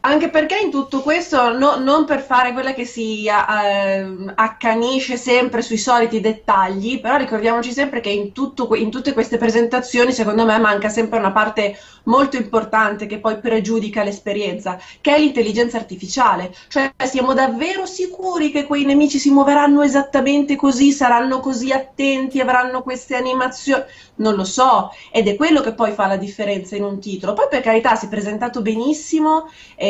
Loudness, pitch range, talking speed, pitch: -17 LUFS, 220-275 Hz, 165 wpm, 245 Hz